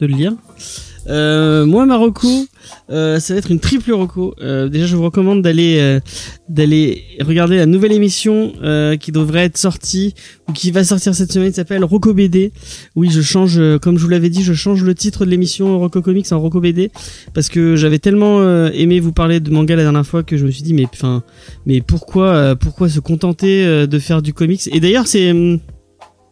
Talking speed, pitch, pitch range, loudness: 215 wpm, 170 Hz, 155-190 Hz, -13 LUFS